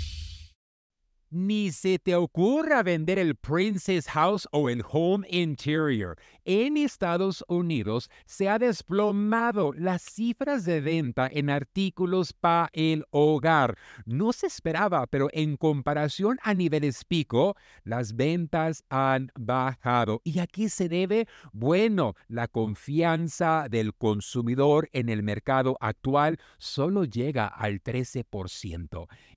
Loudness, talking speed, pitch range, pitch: -27 LUFS, 115 wpm, 120-185 Hz, 155 Hz